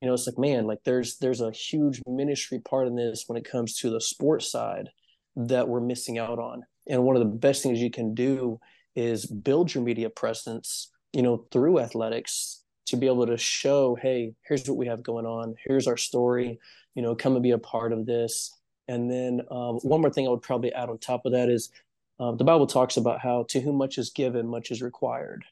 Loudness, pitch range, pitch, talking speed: -27 LUFS, 115-130 Hz, 125 Hz, 230 wpm